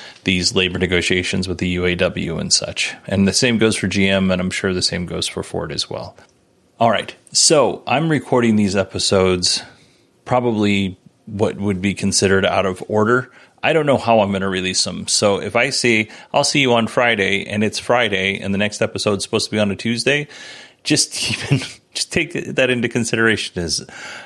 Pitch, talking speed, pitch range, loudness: 105 Hz, 195 wpm, 95-120 Hz, -17 LUFS